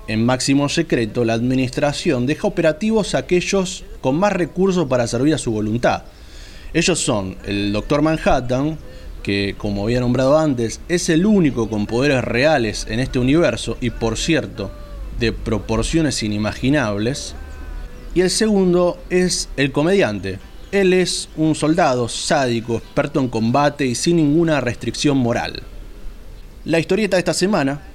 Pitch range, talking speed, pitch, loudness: 115-165 Hz, 140 wpm, 135 Hz, -18 LUFS